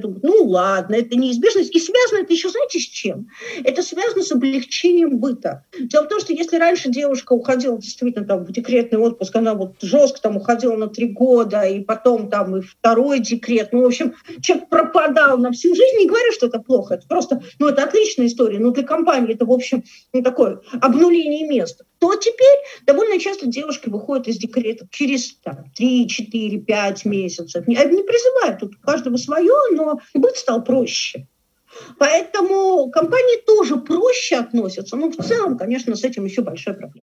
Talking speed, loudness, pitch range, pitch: 180 wpm, -17 LUFS, 230-335 Hz, 260 Hz